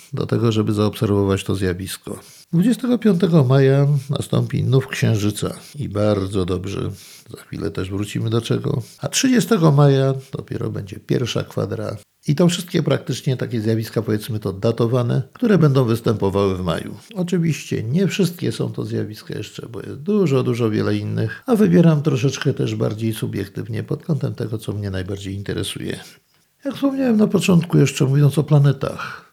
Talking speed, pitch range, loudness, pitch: 155 wpm, 105-155 Hz, -19 LUFS, 130 Hz